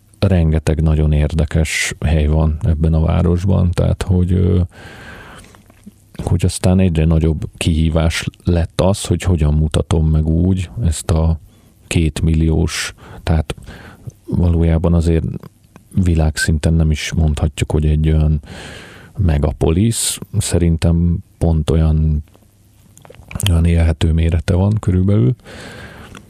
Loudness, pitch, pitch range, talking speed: -16 LUFS, 85 Hz, 80-95 Hz, 100 wpm